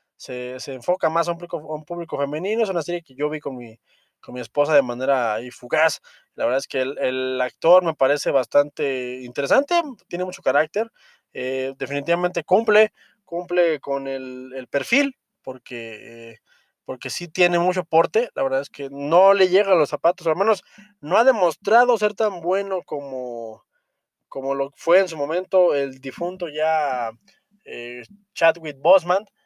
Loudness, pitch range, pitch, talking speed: -21 LUFS, 135-185 Hz, 160 Hz, 175 wpm